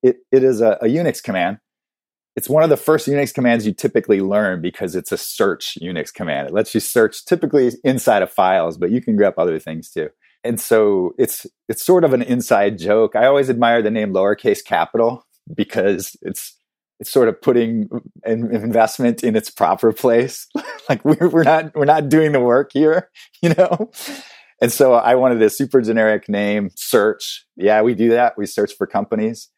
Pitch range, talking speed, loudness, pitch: 115-160 Hz, 195 wpm, -17 LUFS, 130 Hz